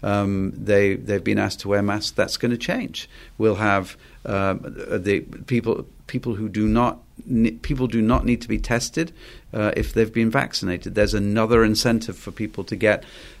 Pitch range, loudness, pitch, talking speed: 100-120 Hz, -22 LUFS, 110 Hz, 195 wpm